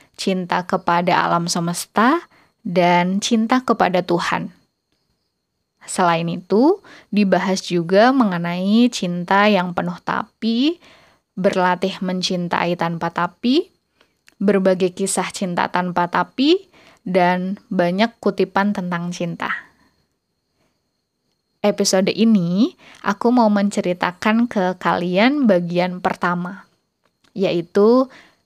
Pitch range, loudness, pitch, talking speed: 180-220 Hz, -19 LUFS, 190 Hz, 85 wpm